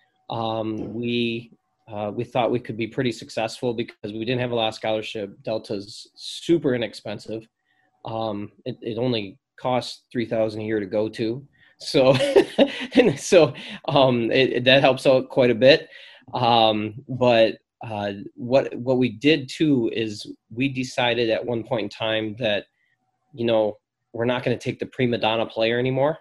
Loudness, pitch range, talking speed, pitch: -22 LUFS, 110-130 Hz, 170 wpm, 120 Hz